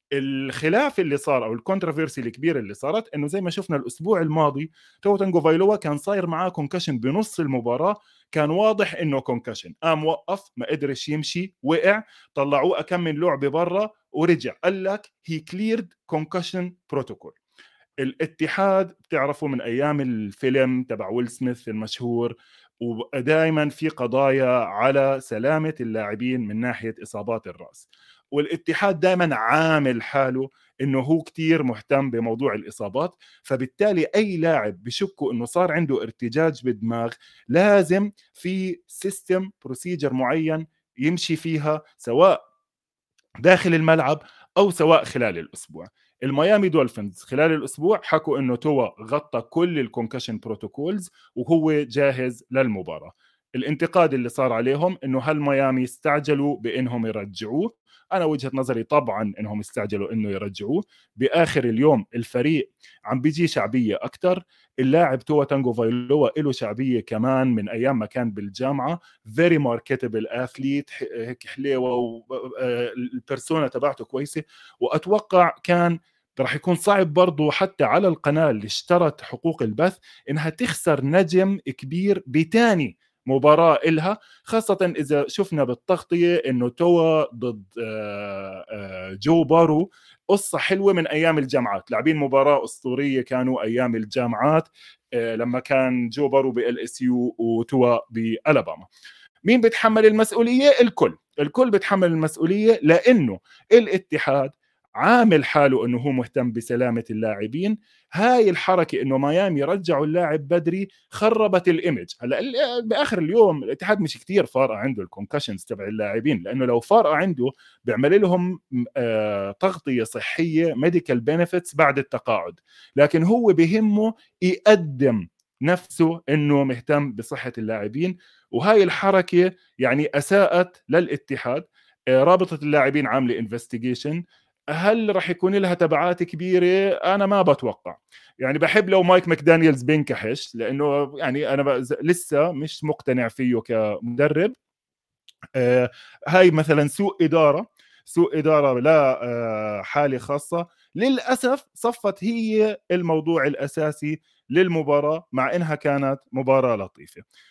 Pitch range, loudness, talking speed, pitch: 130-180 Hz, -22 LUFS, 120 wpm, 150 Hz